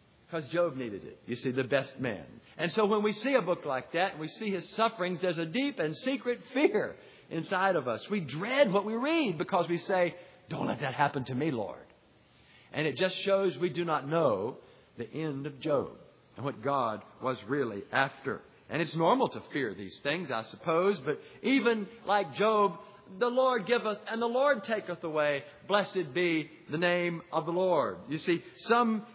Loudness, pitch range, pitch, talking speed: -31 LUFS, 155-215 Hz, 180 Hz, 200 wpm